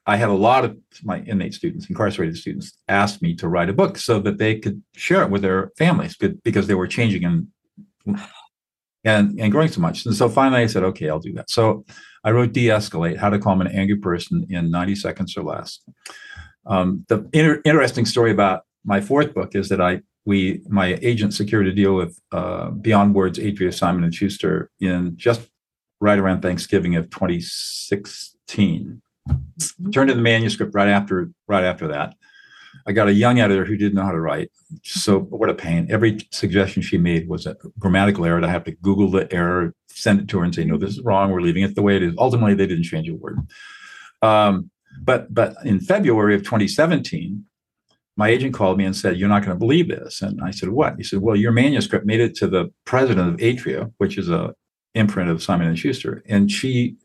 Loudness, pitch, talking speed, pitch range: -20 LUFS, 100 Hz, 210 wpm, 95-120 Hz